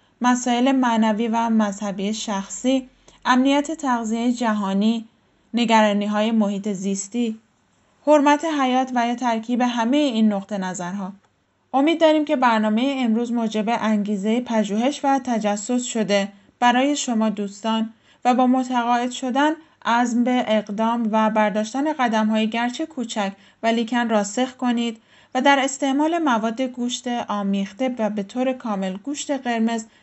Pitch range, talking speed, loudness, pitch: 215-255 Hz, 130 wpm, -21 LUFS, 235 Hz